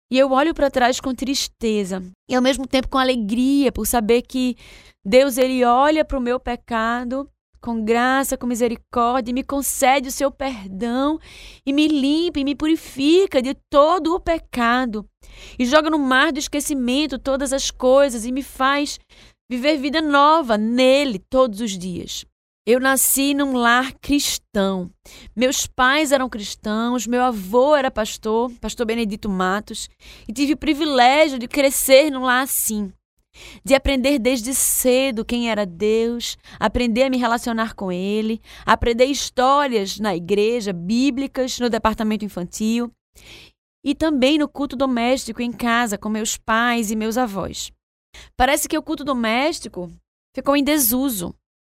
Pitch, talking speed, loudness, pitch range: 255 Hz, 150 wpm, -19 LUFS, 225-275 Hz